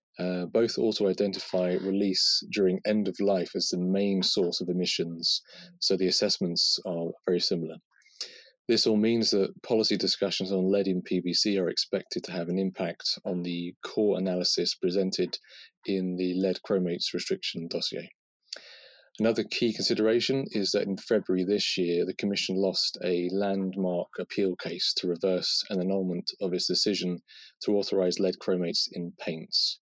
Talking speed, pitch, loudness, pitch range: 155 wpm, 95 Hz, -28 LUFS, 90-100 Hz